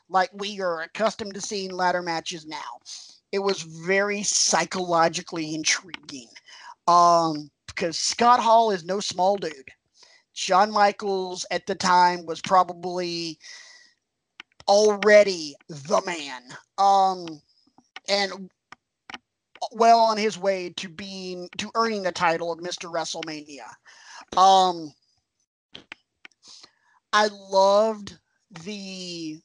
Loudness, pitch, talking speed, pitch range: -23 LUFS, 185 Hz, 105 wpm, 170-205 Hz